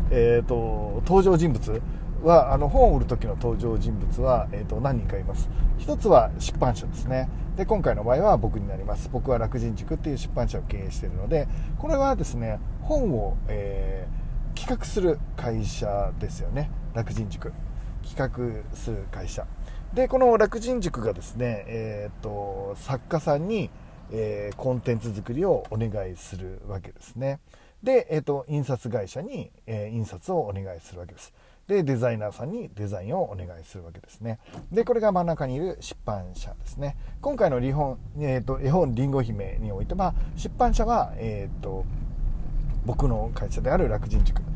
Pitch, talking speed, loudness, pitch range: 120 Hz, 325 characters per minute, -26 LUFS, 105-145 Hz